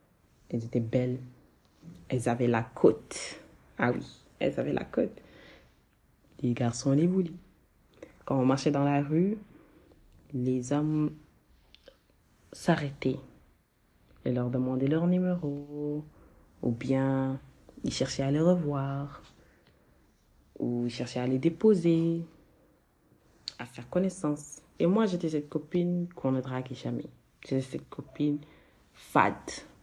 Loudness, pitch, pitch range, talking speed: -30 LUFS, 140 Hz, 125-160 Hz, 120 wpm